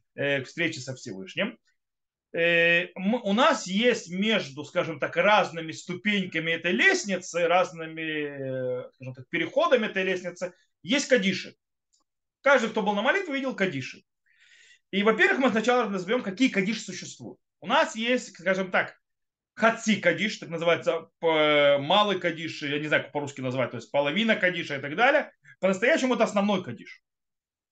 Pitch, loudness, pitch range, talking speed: 185 Hz, -25 LUFS, 160-225 Hz, 140 wpm